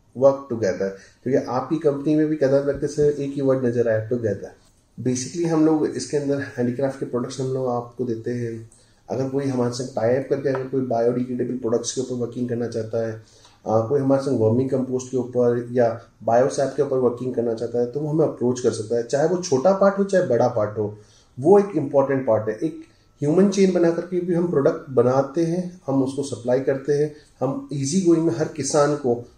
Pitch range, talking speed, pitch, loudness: 120-145 Hz, 210 wpm, 130 Hz, -22 LUFS